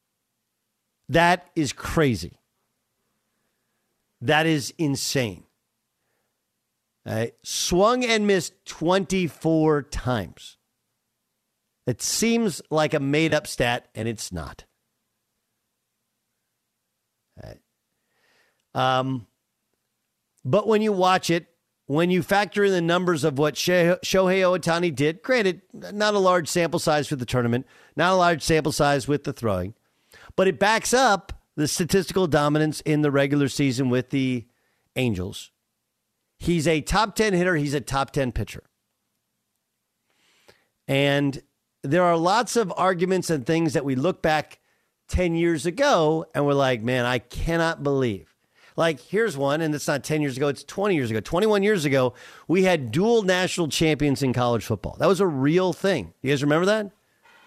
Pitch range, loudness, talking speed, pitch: 130-180 Hz, -23 LUFS, 140 wpm, 155 Hz